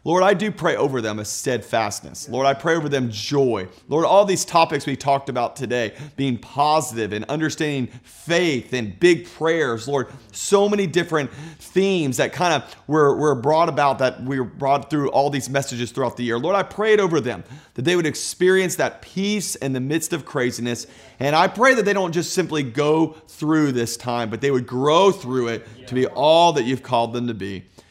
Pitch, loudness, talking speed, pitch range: 140 Hz, -20 LUFS, 210 wpm, 125-165 Hz